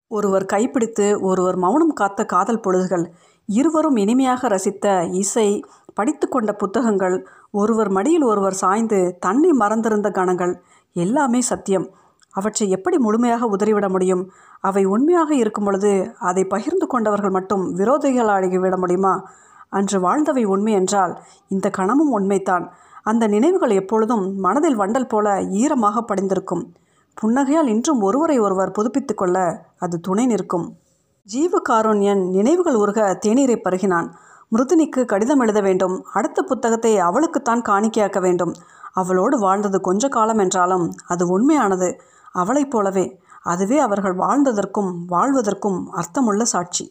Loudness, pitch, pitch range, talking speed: -19 LUFS, 205 Hz, 190-245 Hz, 115 wpm